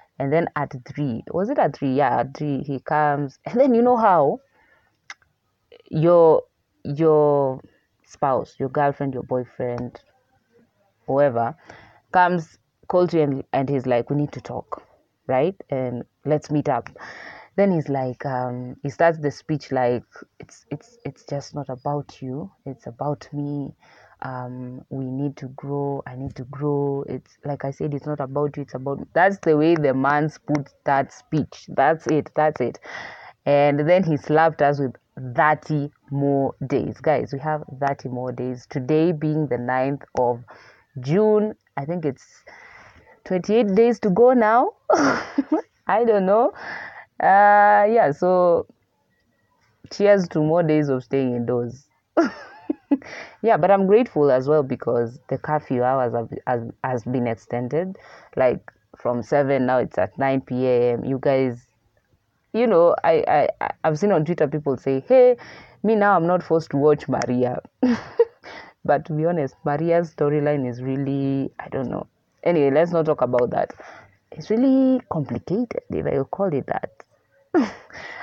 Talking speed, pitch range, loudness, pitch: 155 wpm, 130-170 Hz, -21 LUFS, 145 Hz